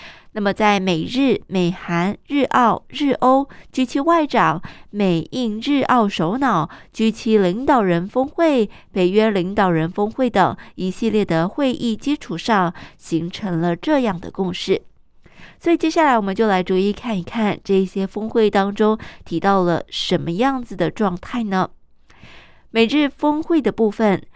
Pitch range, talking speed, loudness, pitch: 185-255 Hz, 225 characters per minute, -19 LUFS, 210 Hz